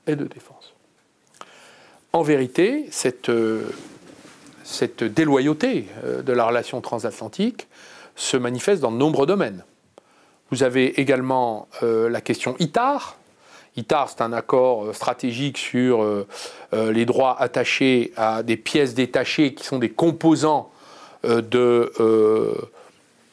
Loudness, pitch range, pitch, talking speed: -21 LUFS, 115-140 Hz, 125 Hz, 130 wpm